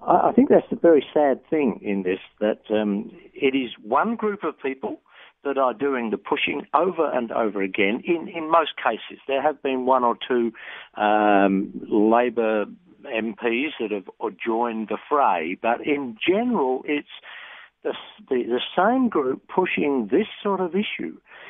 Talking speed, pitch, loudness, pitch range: 160 wpm, 130 Hz, -23 LUFS, 110-170 Hz